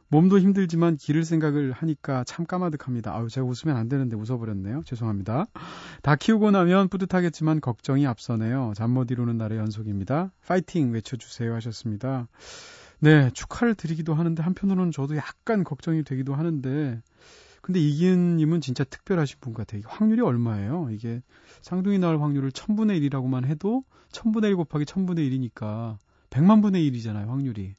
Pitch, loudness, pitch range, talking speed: 145 Hz, -25 LUFS, 120-175 Hz, 385 characters per minute